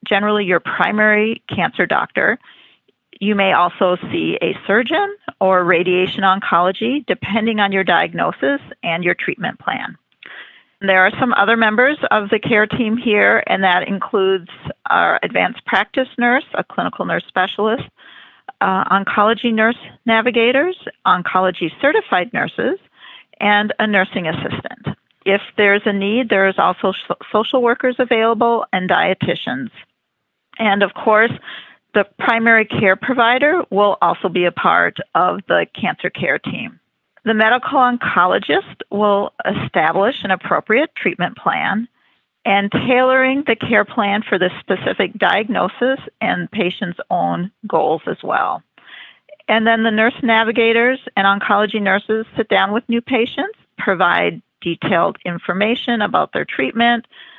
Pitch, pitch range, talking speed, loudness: 215 Hz, 195-235 Hz, 130 wpm, -16 LUFS